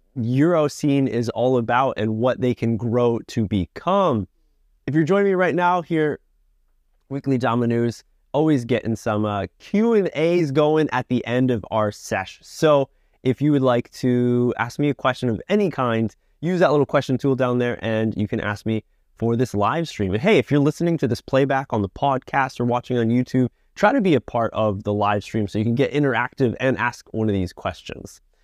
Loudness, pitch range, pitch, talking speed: -21 LUFS, 110-140 Hz, 125 Hz, 210 wpm